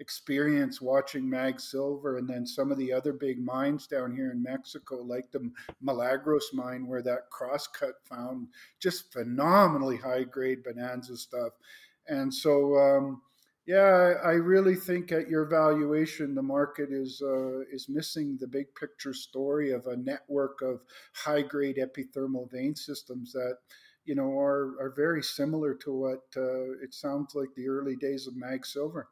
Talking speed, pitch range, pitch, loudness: 155 wpm, 130-145 Hz, 135 Hz, -30 LUFS